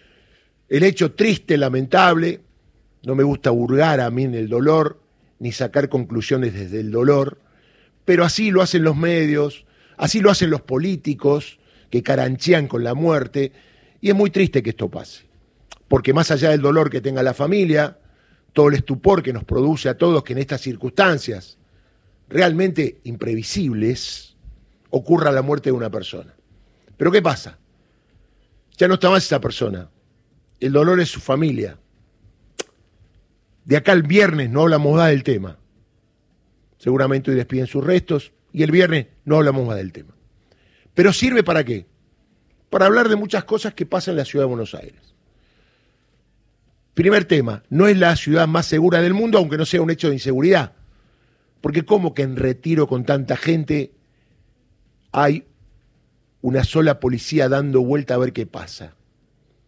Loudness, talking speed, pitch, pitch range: -18 LUFS, 160 wpm, 140 Hz, 120-165 Hz